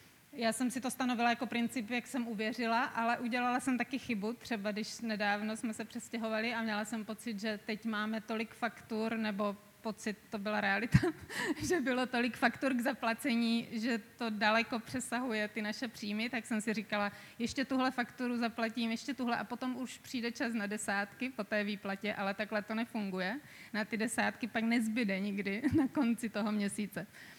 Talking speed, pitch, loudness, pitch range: 180 wpm, 230 Hz, -35 LUFS, 215-245 Hz